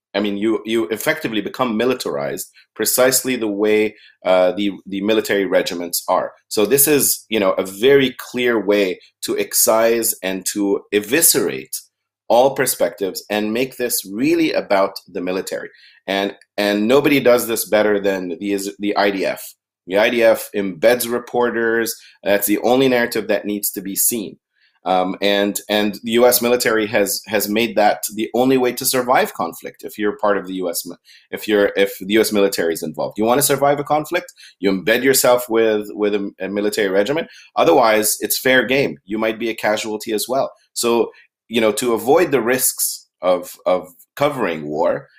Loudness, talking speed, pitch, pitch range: -18 LUFS, 170 wpm, 105 Hz, 100-120 Hz